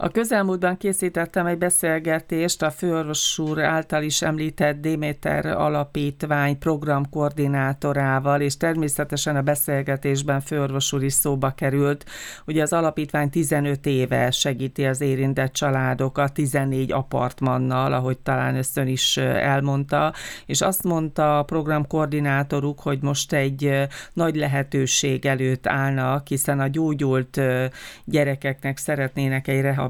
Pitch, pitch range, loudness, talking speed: 145 Hz, 135-155 Hz, -22 LUFS, 110 wpm